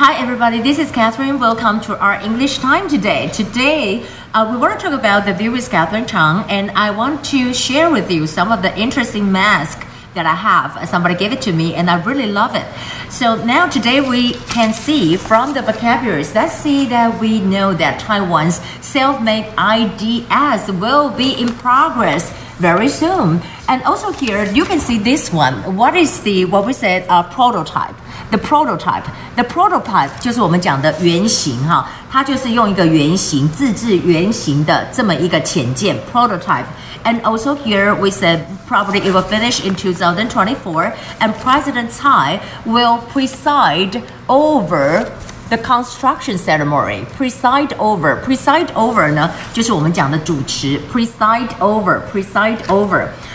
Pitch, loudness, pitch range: 225 Hz, -14 LUFS, 185-255 Hz